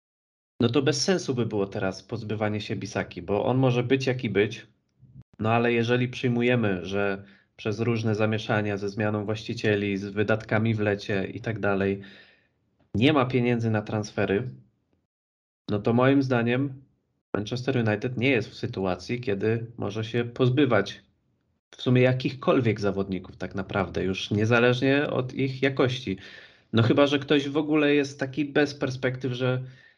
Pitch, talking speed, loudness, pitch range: 115 Hz, 150 wpm, -26 LUFS, 100-130 Hz